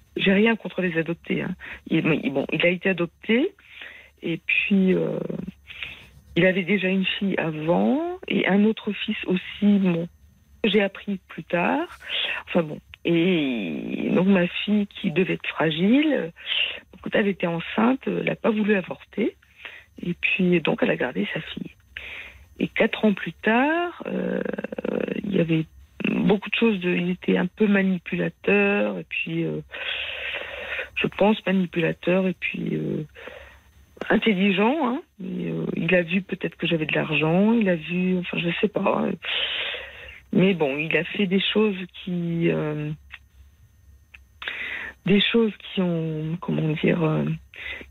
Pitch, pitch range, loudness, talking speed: 190 Hz, 170-215 Hz, -23 LUFS, 150 wpm